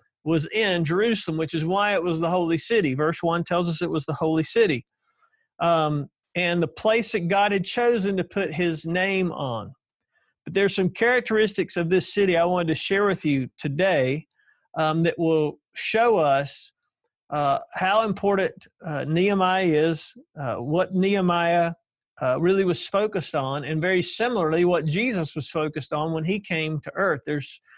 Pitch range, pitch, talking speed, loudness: 155-195 Hz, 175 Hz, 175 wpm, -23 LUFS